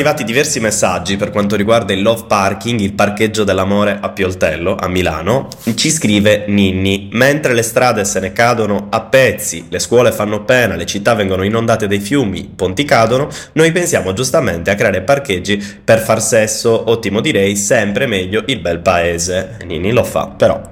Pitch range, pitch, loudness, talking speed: 100-115 Hz, 105 Hz, -13 LUFS, 175 wpm